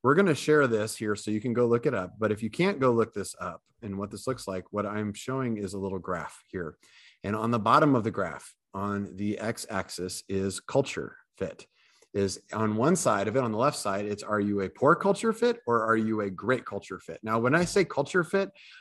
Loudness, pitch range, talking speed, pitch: -28 LUFS, 100-130 Hz, 250 wpm, 110 Hz